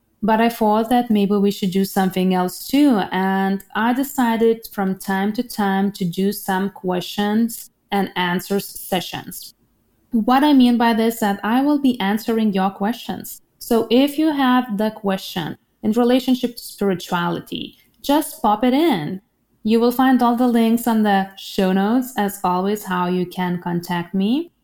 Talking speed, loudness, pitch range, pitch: 170 wpm, -19 LUFS, 195-240 Hz, 210 Hz